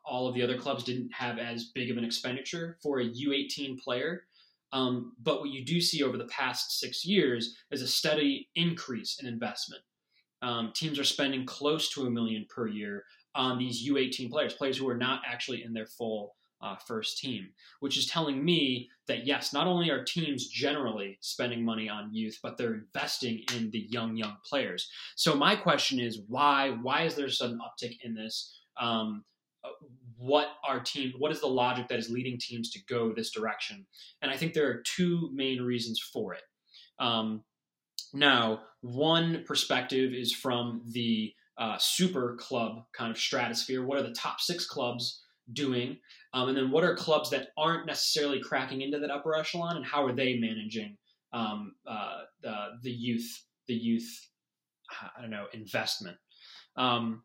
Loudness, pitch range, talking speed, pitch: -31 LUFS, 115-145 Hz, 180 wpm, 125 Hz